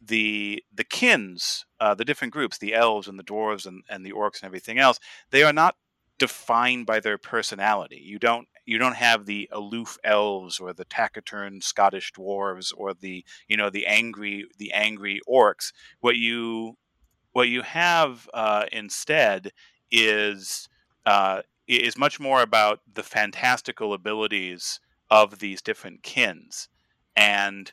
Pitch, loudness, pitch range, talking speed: 105 Hz, -23 LUFS, 100-115 Hz, 150 wpm